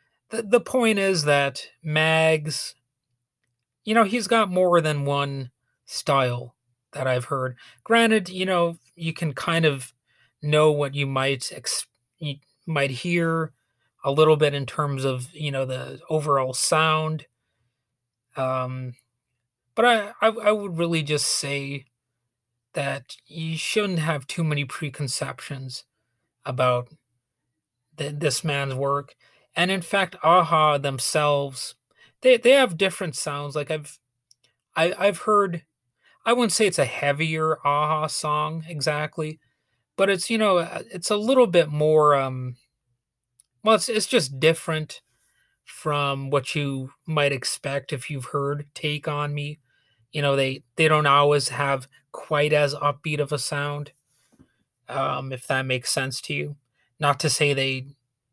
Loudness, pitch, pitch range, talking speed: -23 LUFS, 145 Hz, 130-160 Hz, 140 wpm